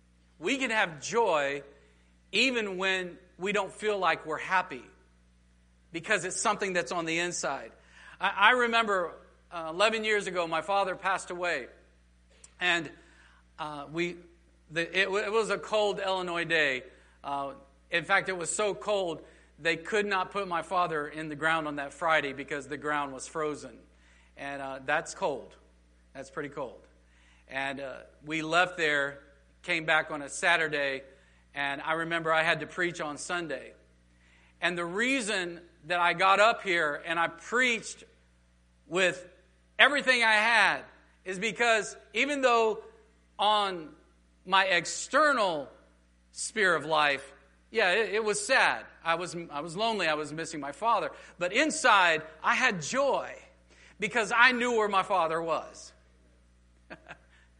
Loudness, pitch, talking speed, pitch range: -28 LUFS, 170 Hz, 140 wpm, 140-200 Hz